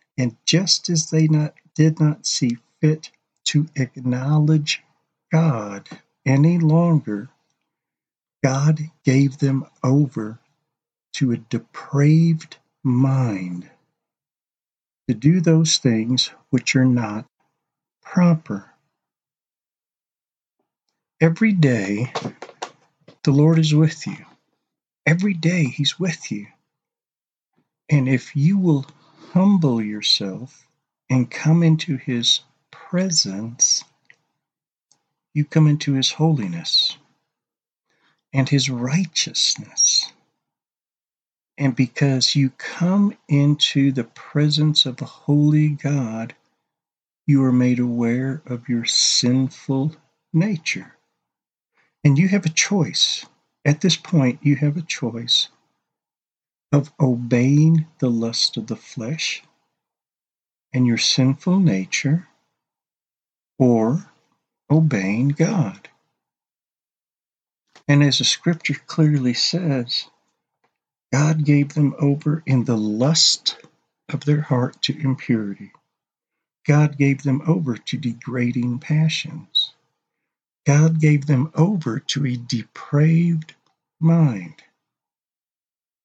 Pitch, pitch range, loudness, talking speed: 145 Hz, 125-160 Hz, -19 LUFS, 95 wpm